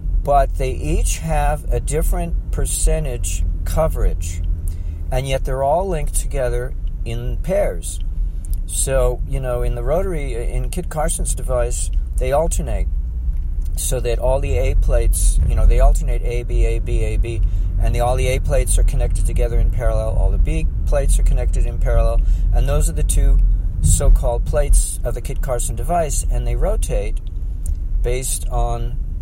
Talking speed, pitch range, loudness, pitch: 165 wpm, 80-120 Hz, -21 LUFS, 90 Hz